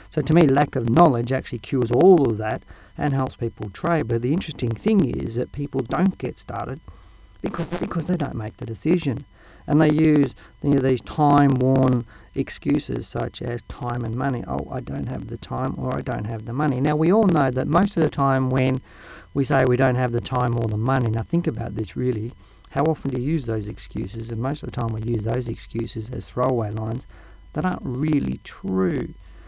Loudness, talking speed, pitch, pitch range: -23 LUFS, 215 wpm, 125 Hz, 115-145 Hz